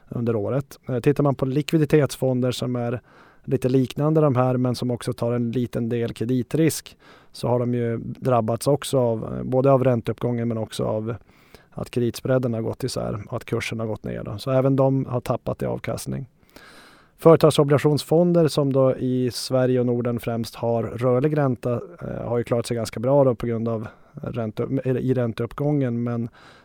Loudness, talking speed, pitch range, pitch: -23 LUFS, 175 wpm, 115-135 Hz, 125 Hz